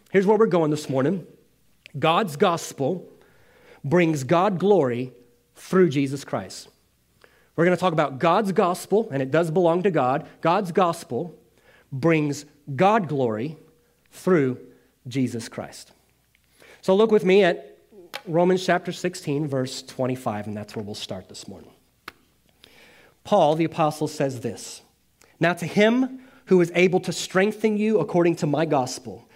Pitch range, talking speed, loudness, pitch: 140-185 Hz, 145 wpm, -22 LUFS, 165 Hz